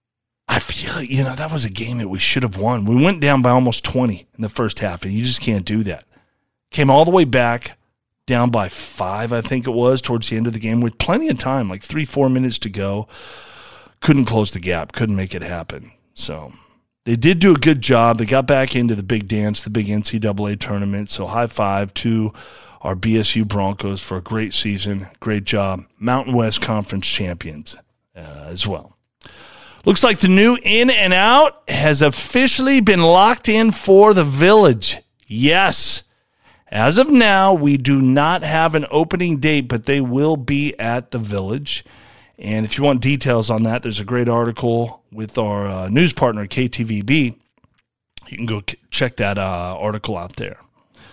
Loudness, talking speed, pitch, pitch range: -17 LUFS, 190 wpm, 120 Hz, 105-140 Hz